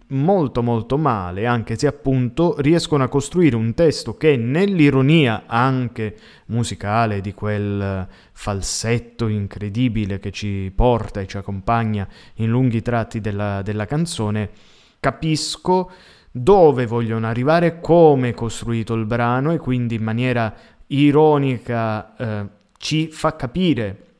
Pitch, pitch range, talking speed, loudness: 120 Hz, 105-140 Hz, 120 wpm, -19 LUFS